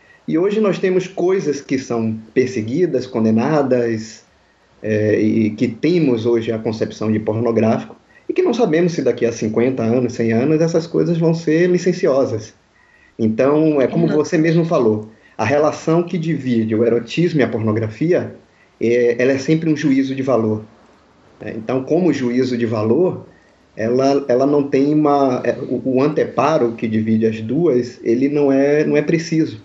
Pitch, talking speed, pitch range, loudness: 130 Hz, 165 wpm, 115-155 Hz, -17 LUFS